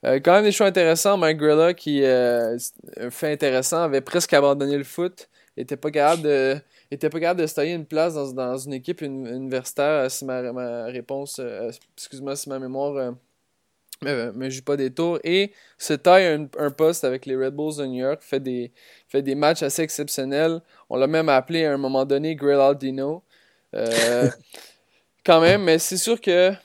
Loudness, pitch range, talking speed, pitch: -22 LUFS, 130-160 Hz, 205 wpm, 140 Hz